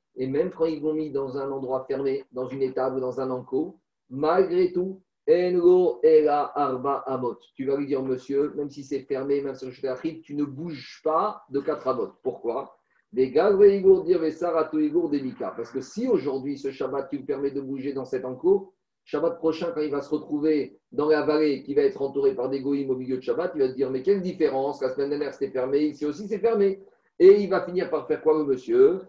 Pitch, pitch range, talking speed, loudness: 145 Hz, 135-180 Hz, 220 wpm, -25 LUFS